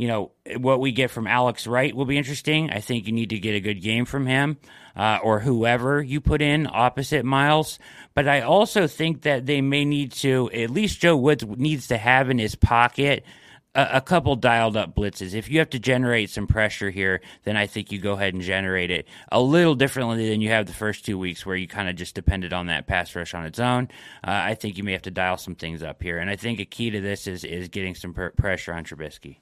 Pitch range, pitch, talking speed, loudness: 100-135 Hz, 115 Hz, 250 wpm, -23 LUFS